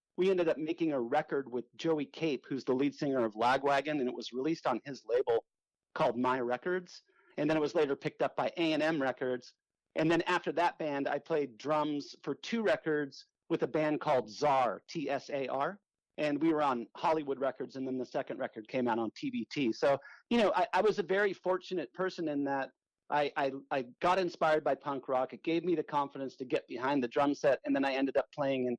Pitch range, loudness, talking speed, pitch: 135-175 Hz, -33 LUFS, 230 wpm, 150 Hz